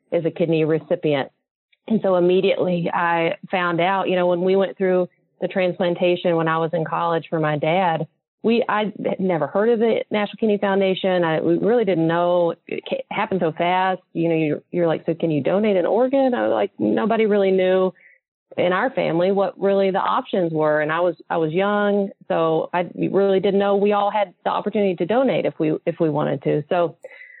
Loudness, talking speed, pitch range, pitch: -20 LUFS, 210 wpm, 170-200 Hz, 180 Hz